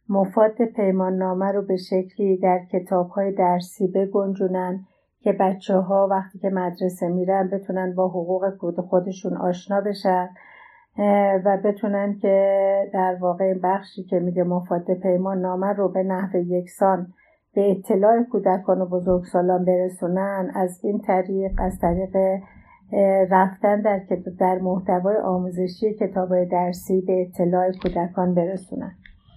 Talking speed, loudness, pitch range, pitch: 125 wpm, -22 LUFS, 185-195 Hz, 190 Hz